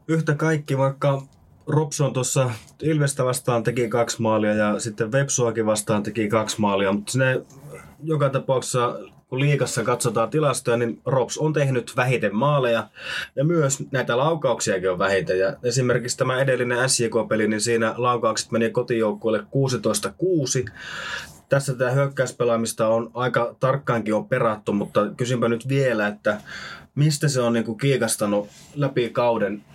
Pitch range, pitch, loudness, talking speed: 115-135 Hz, 125 Hz, -22 LUFS, 135 wpm